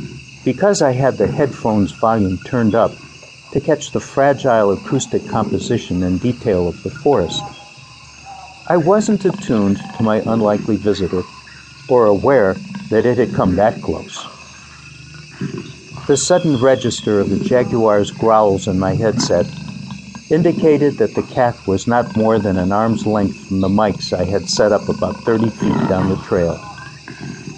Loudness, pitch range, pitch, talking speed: -16 LUFS, 100-140 Hz, 115 Hz, 150 wpm